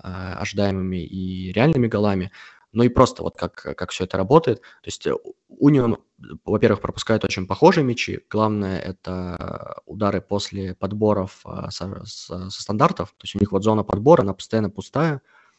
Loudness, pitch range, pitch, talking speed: -22 LUFS, 95-115 Hz, 100 Hz, 155 wpm